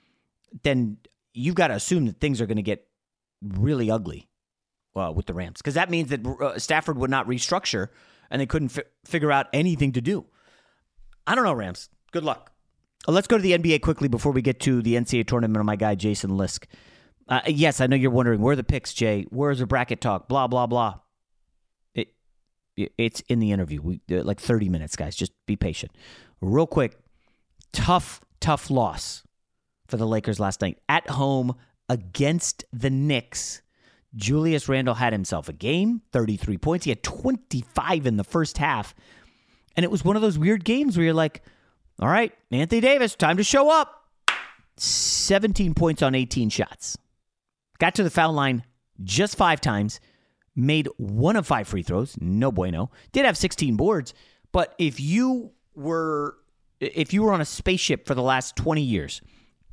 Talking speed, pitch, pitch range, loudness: 180 wpm, 135 Hz, 110-165 Hz, -24 LUFS